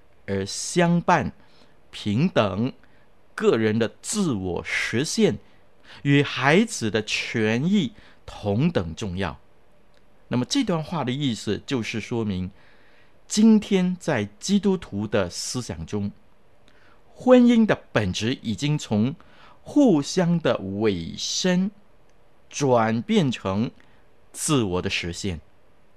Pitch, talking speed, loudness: 120 Hz, 150 characters per minute, -23 LUFS